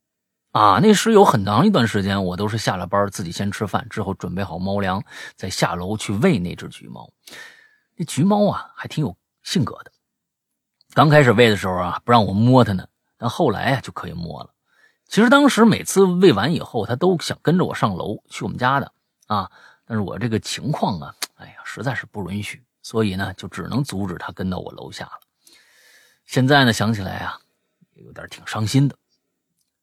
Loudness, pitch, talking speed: -19 LUFS, 115 Hz, 280 characters per minute